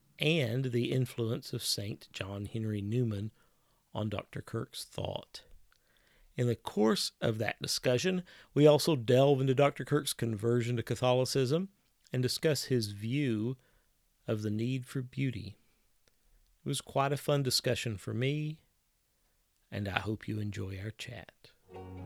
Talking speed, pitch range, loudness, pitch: 140 wpm, 110-135 Hz, -32 LUFS, 120 Hz